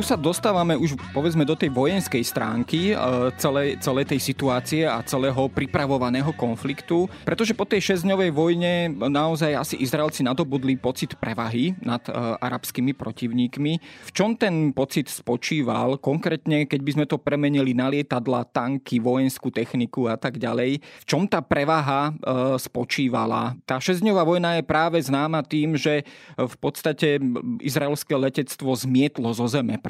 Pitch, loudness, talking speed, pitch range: 140 Hz, -23 LUFS, 145 wpm, 130-160 Hz